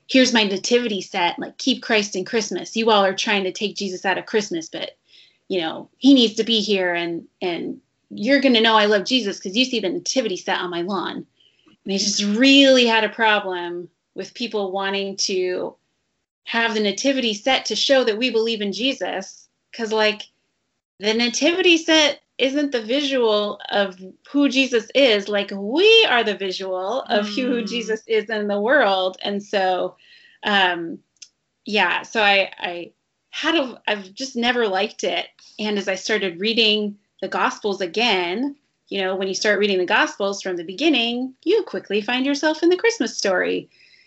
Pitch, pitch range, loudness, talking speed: 215 Hz, 195-260 Hz, -20 LUFS, 180 wpm